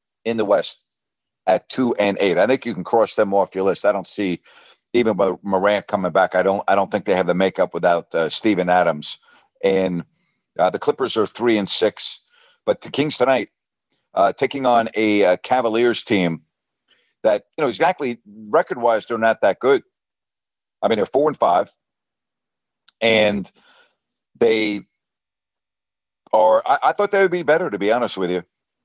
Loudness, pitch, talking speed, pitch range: -19 LUFS, 110 Hz, 180 wpm, 100-135 Hz